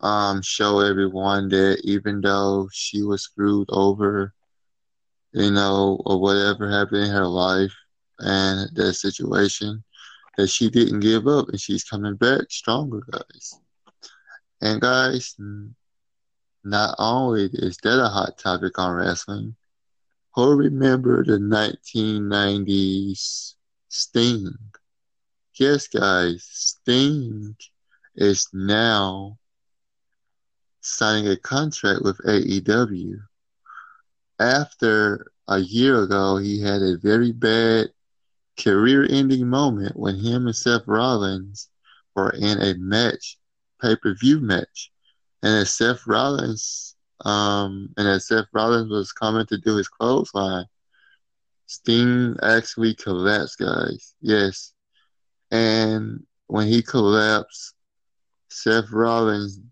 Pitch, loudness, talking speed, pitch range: 105 Hz, -21 LUFS, 110 wpm, 100-115 Hz